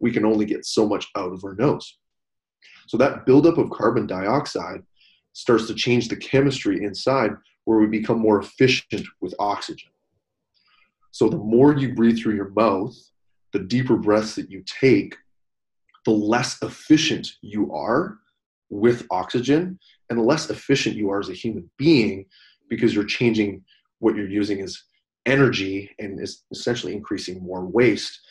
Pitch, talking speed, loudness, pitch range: 110 Hz, 155 wpm, -21 LUFS, 100-125 Hz